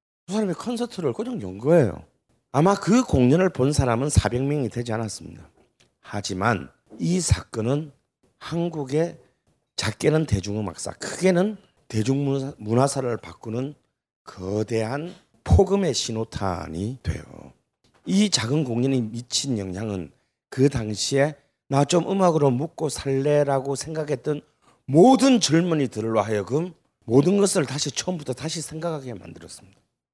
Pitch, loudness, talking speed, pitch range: 135 Hz, -23 LUFS, 285 characters per minute, 110-160 Hz